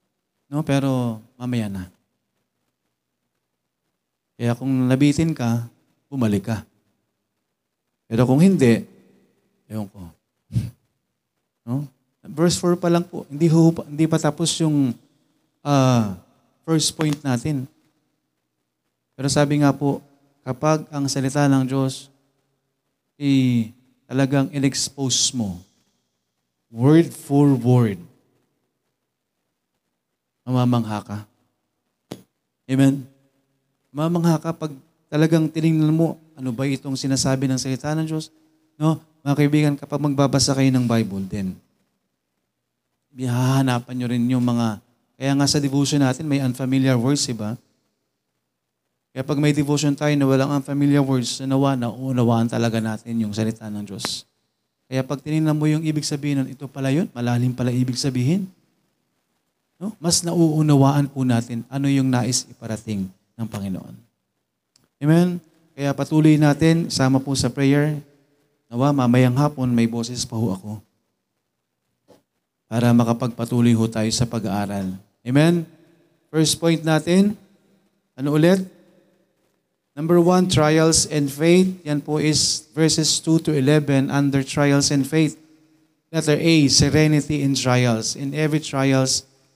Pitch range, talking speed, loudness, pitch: 120-155 Hz, 125 wpm, -20 LUFS, 135 Hz